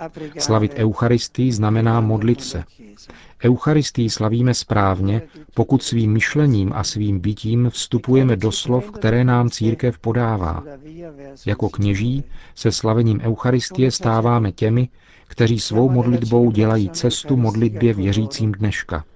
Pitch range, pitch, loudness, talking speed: 110-125 Hz, 115 Hz, -19 LUFS, 115 wpm